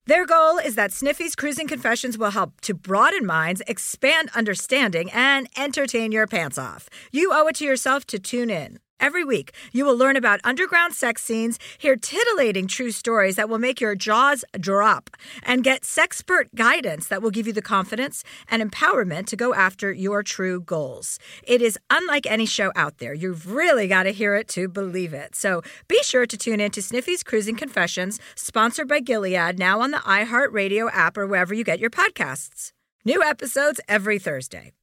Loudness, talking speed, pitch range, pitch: -21 LUFS, 185 wpm, 195-270 Hz, 225 Hz